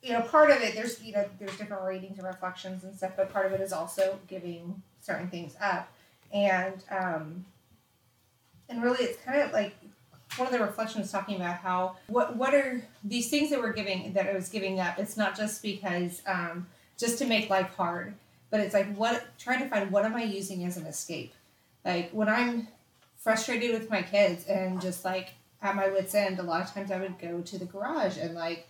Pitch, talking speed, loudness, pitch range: 195 Hz, 215 wpm, -30 LUFS, 185-220 Hz